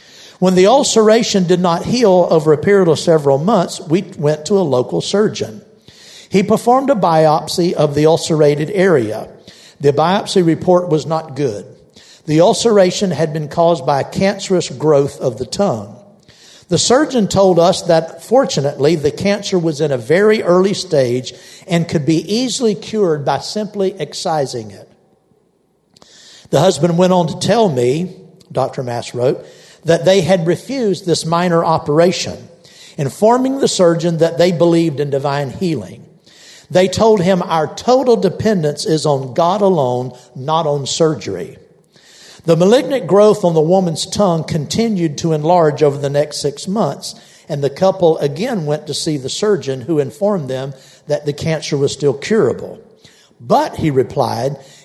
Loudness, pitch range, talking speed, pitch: -14 LUFS, 150-195 Hz, 155 wpm, 170 Hz